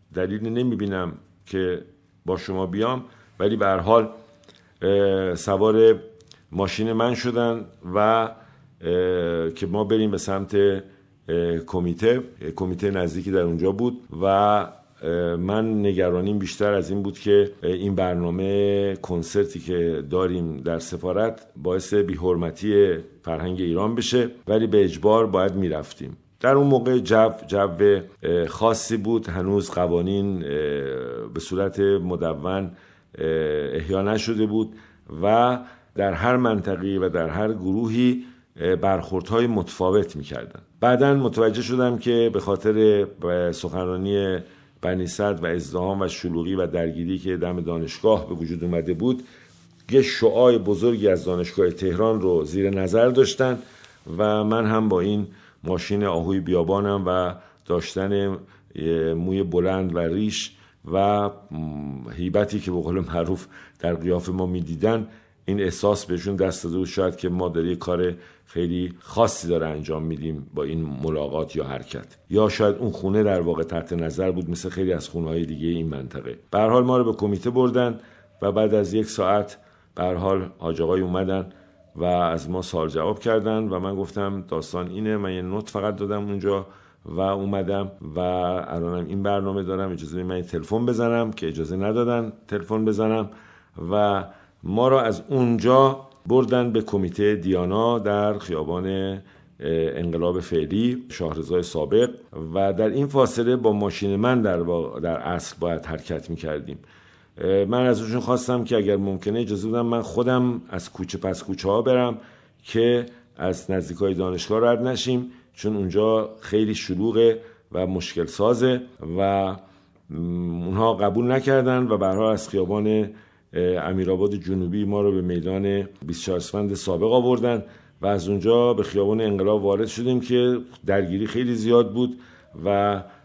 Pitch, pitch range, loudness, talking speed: 100 Hz, 90-110 Hz, -23 LUFS, 140 wpm